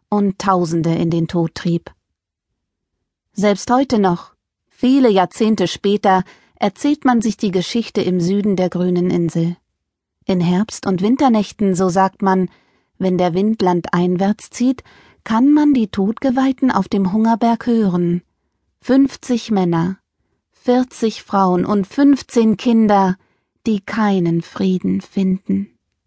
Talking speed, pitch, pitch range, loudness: 120 wpm, 200 Hz, 180-230 Hz, -17 LUFS